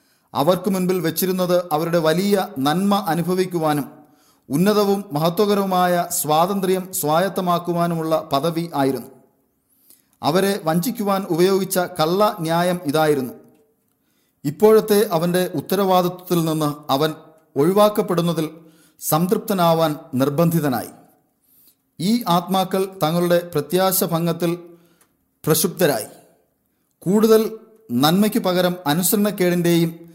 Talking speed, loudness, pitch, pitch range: 75 wpm, -19 LUFS, 175 Hz, 160-190 Hz